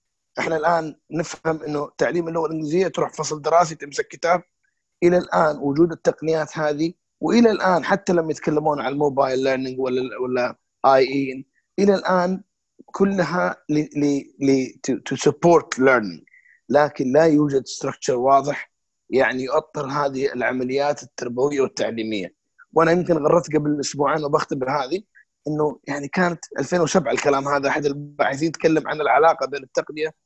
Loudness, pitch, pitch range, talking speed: -21 LUFS, 150 Hz, 140-170 Hz, 130 wpm